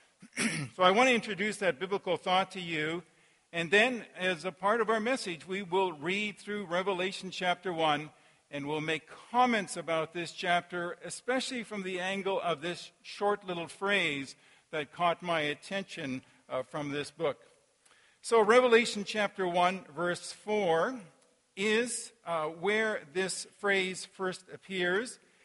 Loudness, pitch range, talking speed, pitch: -31 LUFS, 170-210 Hz, 145 wpm, 185 Hz